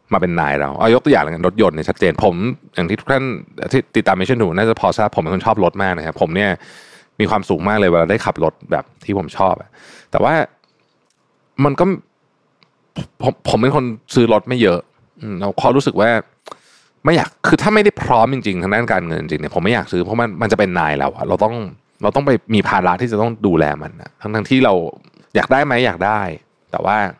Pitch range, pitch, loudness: 95-130 Hz, 110 Hz, -16 LUFS